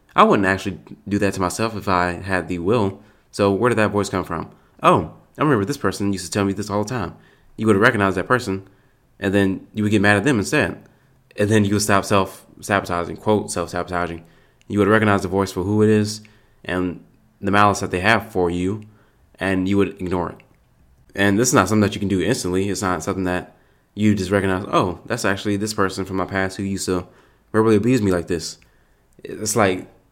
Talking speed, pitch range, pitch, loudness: 225 wpm, 95-105 Hz, 100 Hz, -20 LUFS